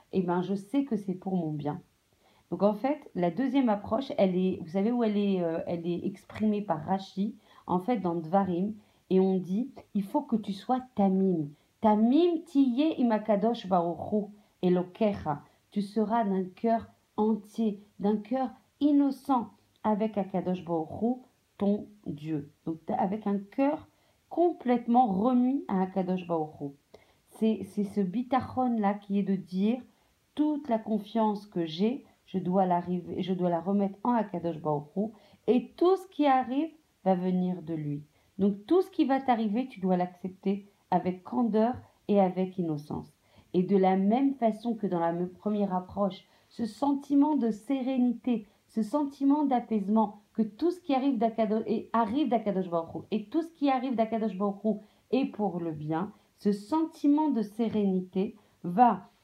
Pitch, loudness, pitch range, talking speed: 210 Hz, -29 LUFS, 185-240 Hz, 160 wpm